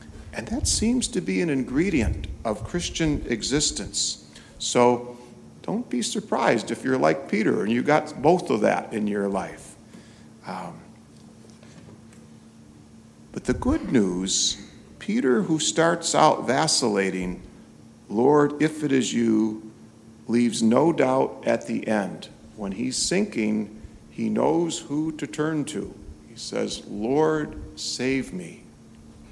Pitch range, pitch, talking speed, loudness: 95-155 Hz, 120 Hz, 125 wpm, -24 LUFS